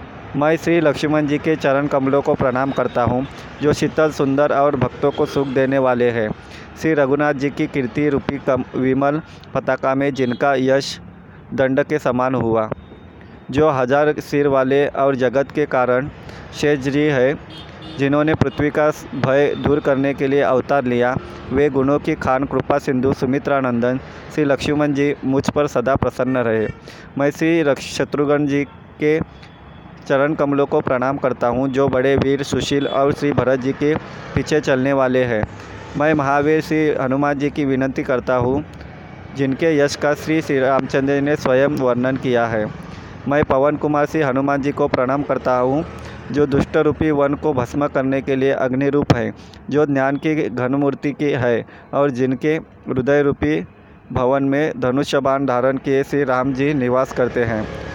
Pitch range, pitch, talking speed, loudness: 130-145 Hz, 140 Hz, 165 wpm, -18 LUFS